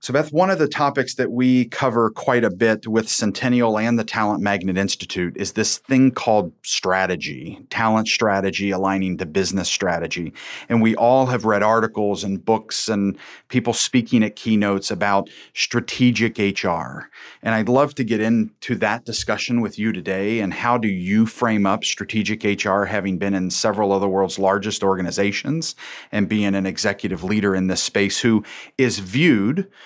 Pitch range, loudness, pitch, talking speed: 100-120 Hz, -20 LUFS, 110 Hz, 170 wpm